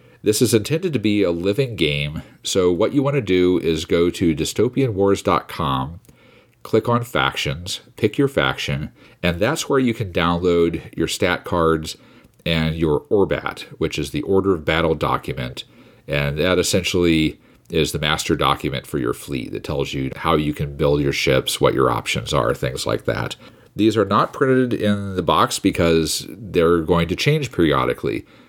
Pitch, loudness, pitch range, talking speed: 90 Hz, -20 LUFS, 80-110 Hz, 175 wpm